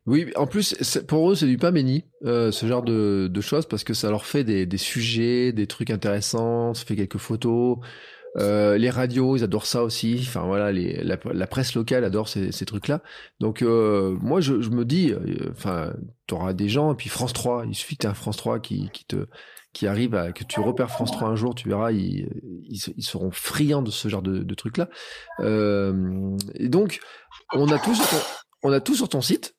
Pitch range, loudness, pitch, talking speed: 105-130 Hz, -24 LUFS, 115 Hz, 225 wpm